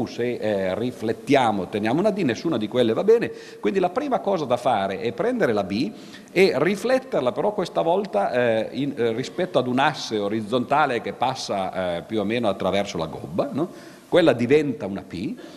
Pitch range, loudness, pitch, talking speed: 110-155 Hz, -23 LUFS, 120 Hz, 185 wpm